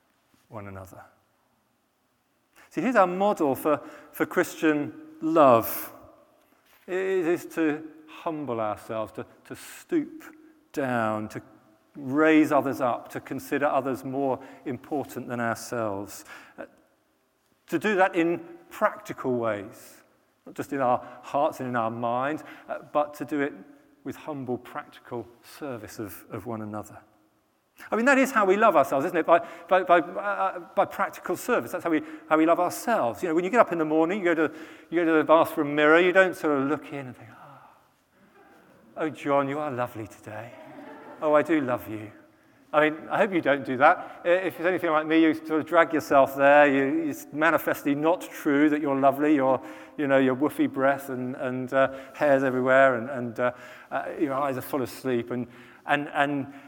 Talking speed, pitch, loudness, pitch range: 180 wpm, 150 Hz, -25 LUFS, 130-175 Hz